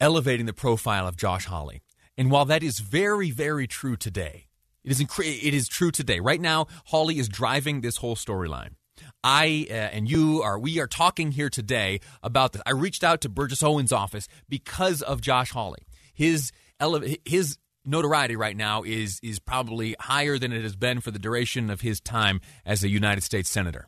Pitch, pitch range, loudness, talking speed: 125 Hz, 105-150 Hz, -25 LUFS, 195 wpm